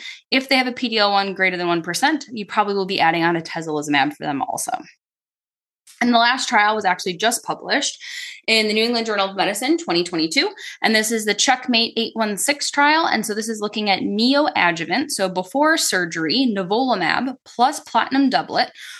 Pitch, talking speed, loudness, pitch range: 220 Hz, 180 wpm, -19 LUFS, 190-260 Hz